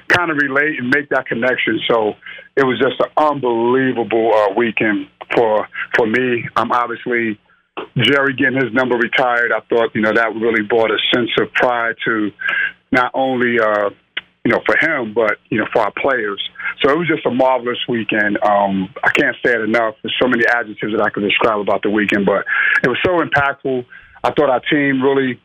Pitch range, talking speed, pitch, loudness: 110-135 Hz, 200 wpm, 120 Hz, -16 LUFS